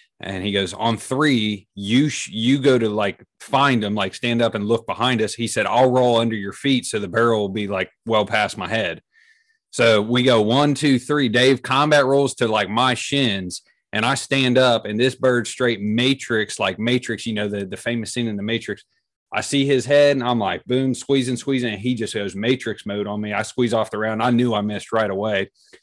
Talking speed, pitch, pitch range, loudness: 230 wpm, 120 Hz, 110-130 Hz, -20 LUFS